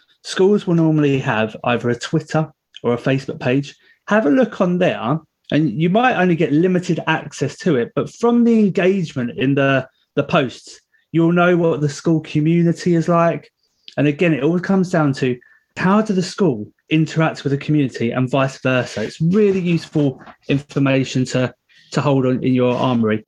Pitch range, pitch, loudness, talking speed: 135-180 Hz, 155 Hz, -18 LUFS, 180 wpm